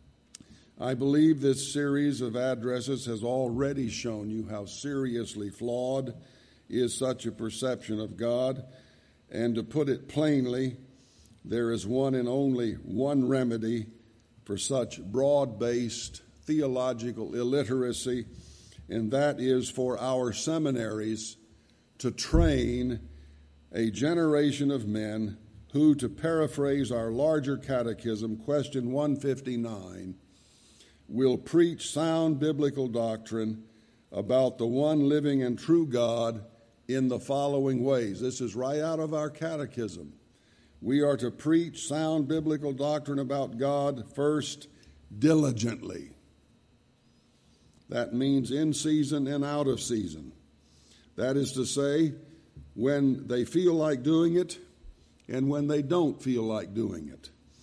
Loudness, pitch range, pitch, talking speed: -29 LUFS, 115-145 Hz, 130 Hz, 120 wpm